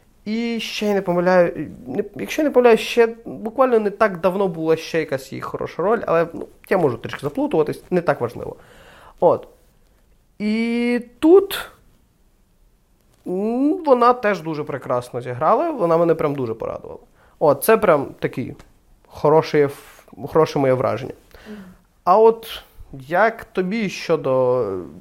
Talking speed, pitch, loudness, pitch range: 130 wpm, 195 Hz, -19 LUFS, 155-230 Hz